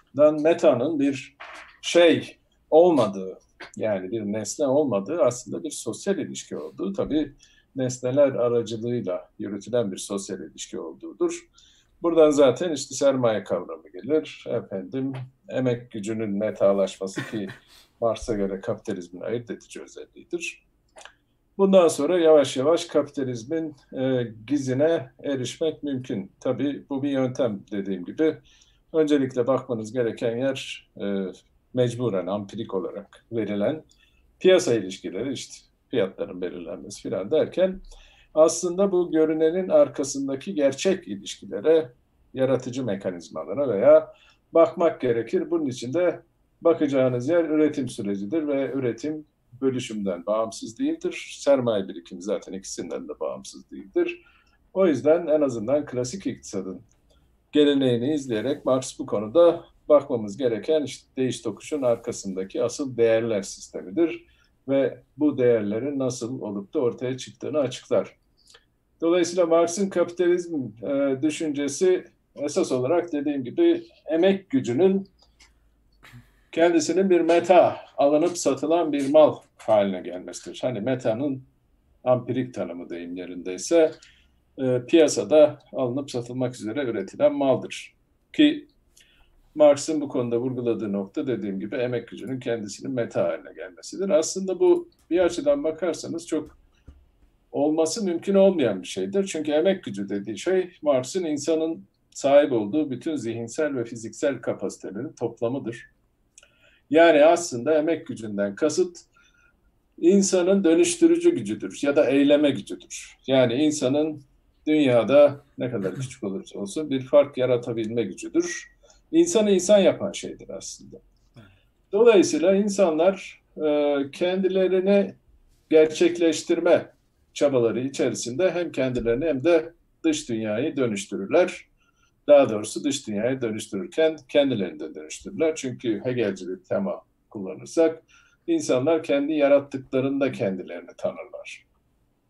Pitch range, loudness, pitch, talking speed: 115-170 Hz, -24 LUFS, 145 Hz, 110 wpm